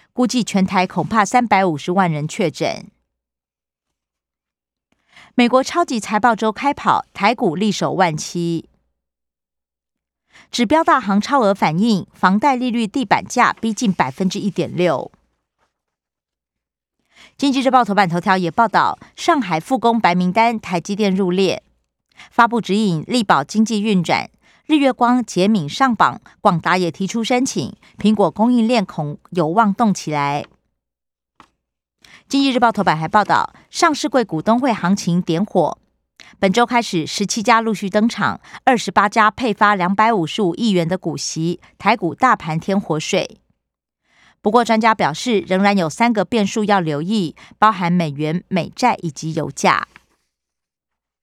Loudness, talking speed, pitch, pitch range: -17 LUFS, 220 characters per minute, 200 Hz, 170-230 Hz